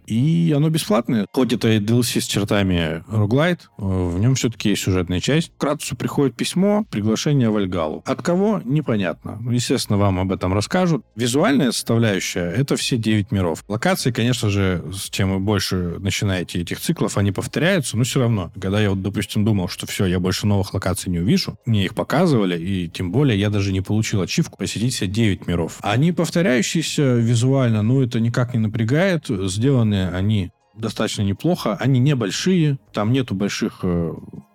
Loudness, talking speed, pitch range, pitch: -20 LUFS, 165 wpm, 95-135 Hz, 110 Hz